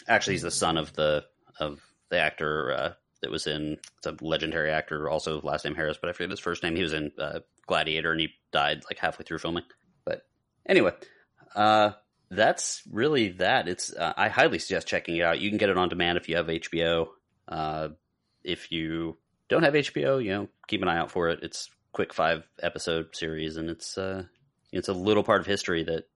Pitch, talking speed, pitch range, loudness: 85 Hz, 210 wpm, 80-95 Hz, -28 LUFS